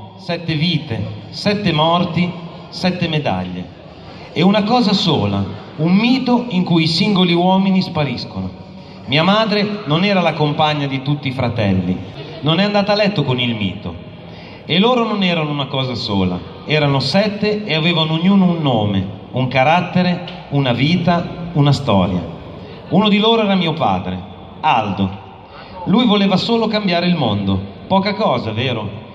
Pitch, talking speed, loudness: 155 Hz, 150 wpm, -16 LUFS